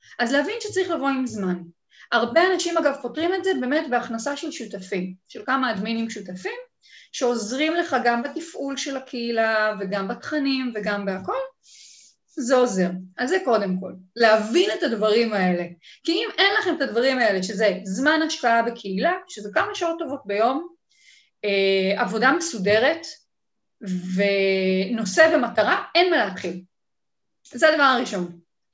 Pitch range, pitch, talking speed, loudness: 200-315 Hz, 240 Hz, 140 wpm, -22 LUFS